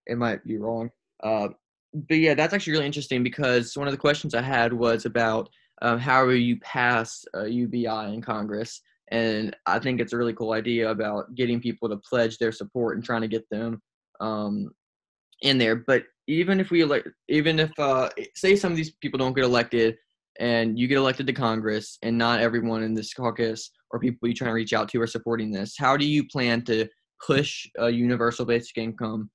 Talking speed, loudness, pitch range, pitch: 205 wpm, -25 LUFS, 115-130 Hz, 120 Hz